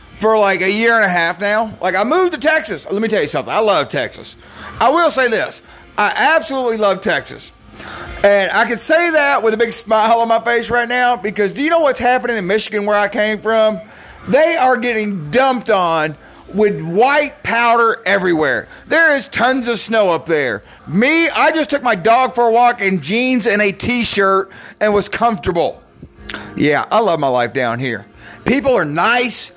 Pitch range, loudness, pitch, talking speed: 210-255 Hz, -14 LUFS, 230 Hz, 200 wpm